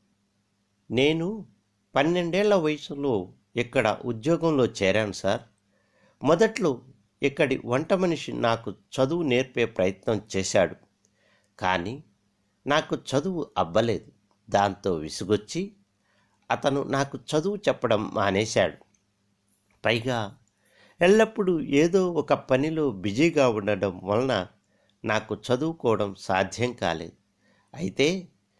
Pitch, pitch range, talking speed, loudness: 120 Hz, 100-150 Hz, 85 wpm, -26 LUFS